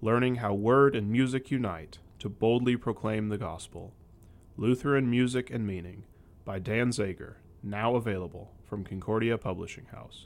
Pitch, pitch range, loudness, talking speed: 105 Hz, 95-120 Hz, -29 LUFS, 140 wpm